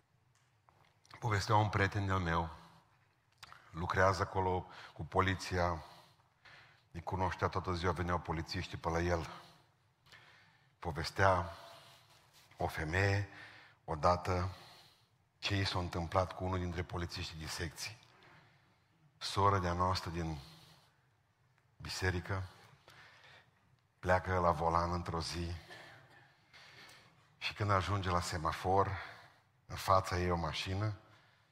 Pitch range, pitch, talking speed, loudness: 85-105 Hz, 95 Hz, 95 wpm, -36 LUFS